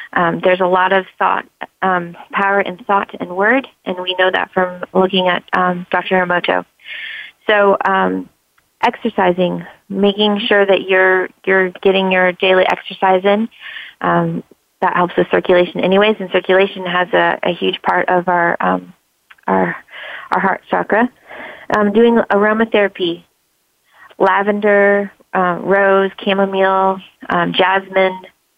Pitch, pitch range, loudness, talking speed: 190 Hz, 180-200 Hz, -15 LUFS, 135 wpm